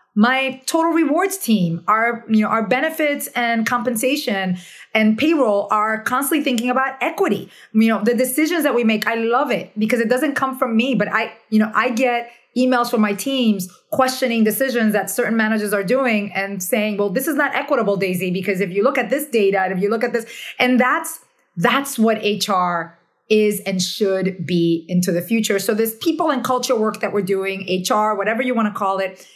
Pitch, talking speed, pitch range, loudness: 225 Hz, 205 wpm, 205-255 Hz, -19 LUFS